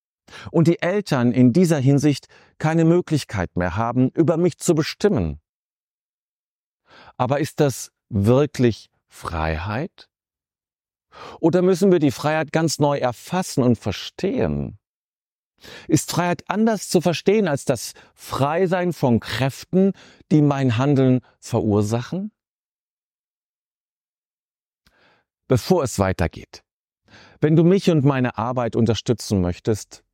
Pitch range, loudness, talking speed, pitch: 115-170 Hz, -20 LUFS, 110 wpm, 140 Hz